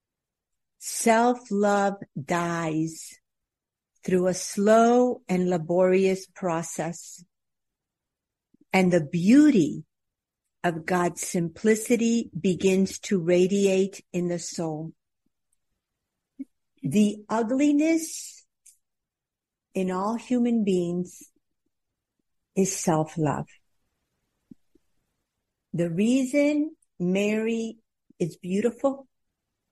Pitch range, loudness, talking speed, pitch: 175-230 Hz, -25 LUFS, 65 wpm, 190 Hz